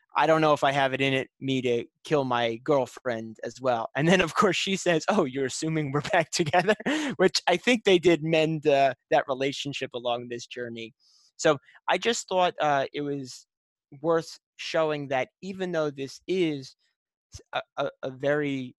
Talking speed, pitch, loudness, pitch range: 185 wpm, 145 Hz, -26 LUFS, 130-175 Hz